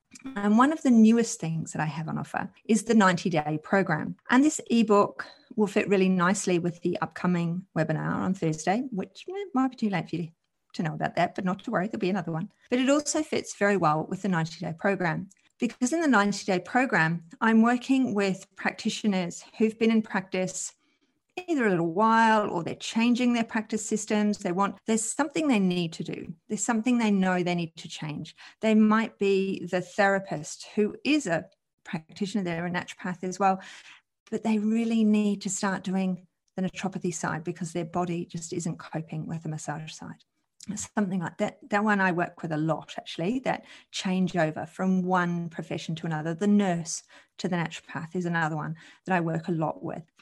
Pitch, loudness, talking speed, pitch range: 190 Hz, -27 LUFS, 195 wpm, 175-220 Hz